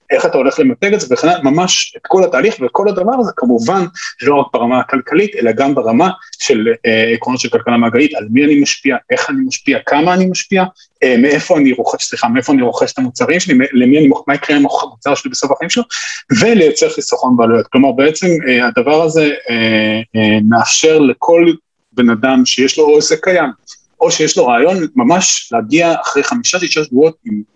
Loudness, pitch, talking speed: -12 LUFS, 180 Hz, 195 wpm